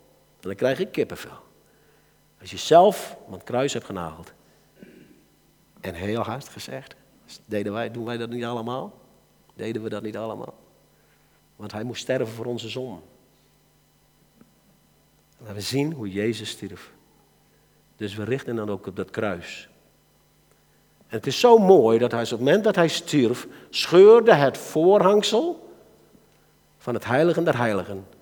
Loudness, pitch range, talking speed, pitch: -22 LUFS, 105-135 Hz, 150 wpm, 115 Hz